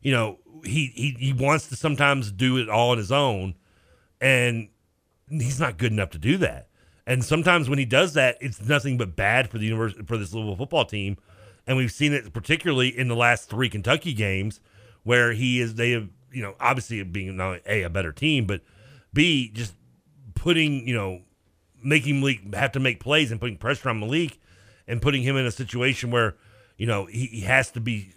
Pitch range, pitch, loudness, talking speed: 105-135 Hz, 120 Hz, -24 LUFS, 205 wpm